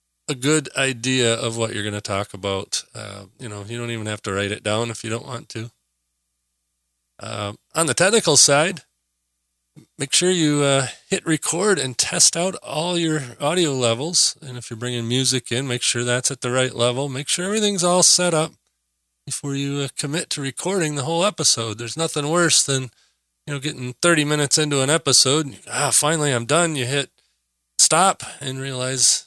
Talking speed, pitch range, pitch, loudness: 195 wpm, 110-150 Hz, 130 Hz, -19 LUFS